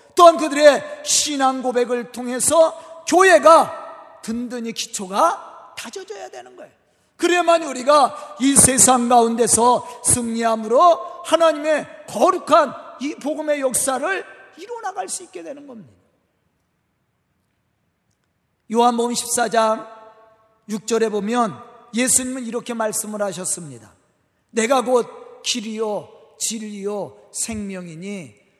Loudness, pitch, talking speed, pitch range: -18 LUFS, 245 Hz, 235 characters per minute, 220-310 Hz